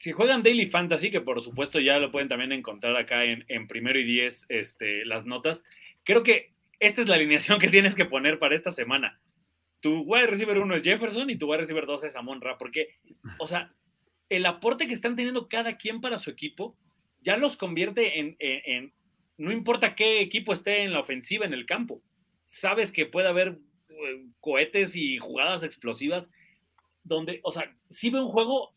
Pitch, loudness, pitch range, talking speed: 185 Hz, -26 LUFS, 145-220 Hz, 195 wpm